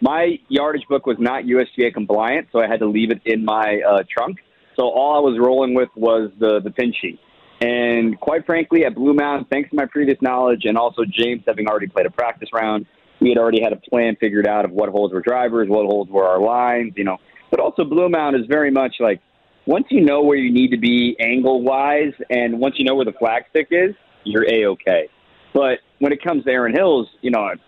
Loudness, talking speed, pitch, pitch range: -18 LUFS, 230 wpm, 120 Hz, 110-140 Hz